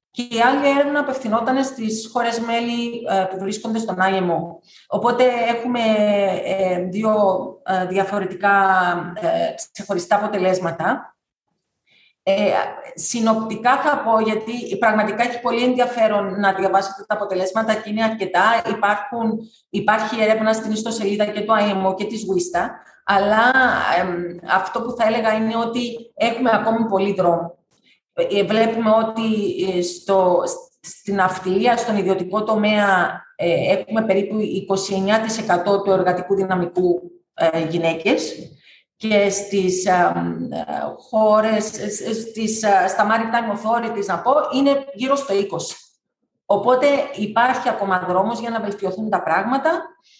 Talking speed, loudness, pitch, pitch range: 115 wpm, -19 LUFS, 215 Hz, 190-230 Hz